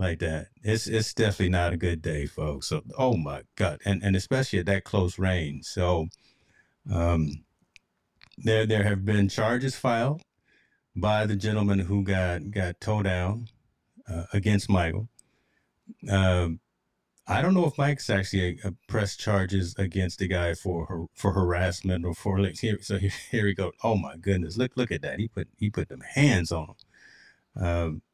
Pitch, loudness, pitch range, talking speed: 95 Hz, -27 LUFS, 90-110 Hz, 175 wpm